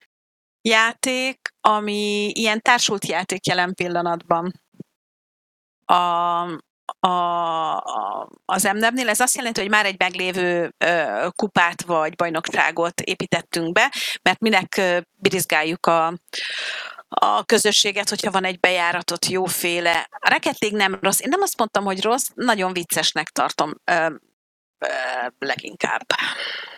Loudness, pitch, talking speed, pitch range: -20 LUFS, 185 Hz, 120 wpm, 175-215 Hz